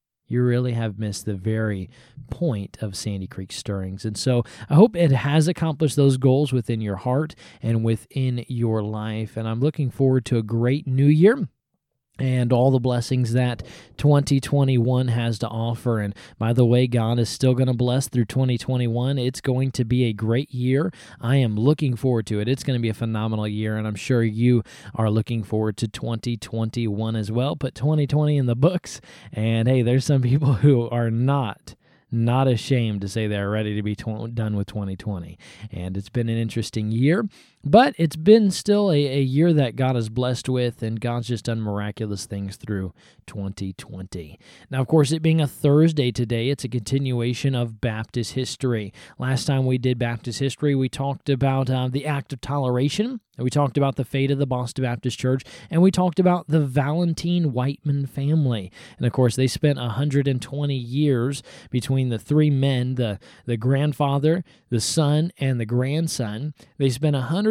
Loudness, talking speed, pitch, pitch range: -22 LUFS, 185 wpm, 125 Hz, 115-140 Hz